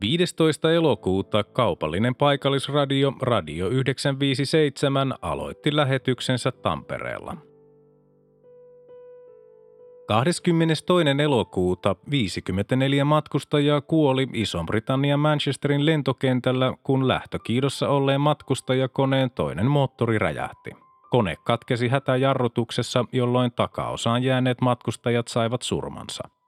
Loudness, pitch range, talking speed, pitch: -23 LUFS, 125-150 Hz, 75 wpm, 135 Hz